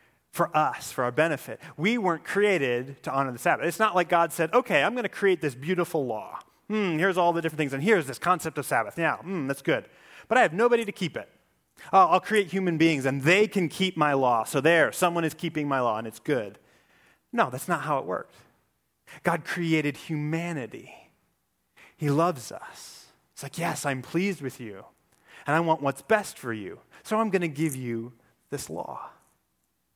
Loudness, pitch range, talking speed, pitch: -26 LUFS, 140-180 Hz, 205 wpm, 160 Hz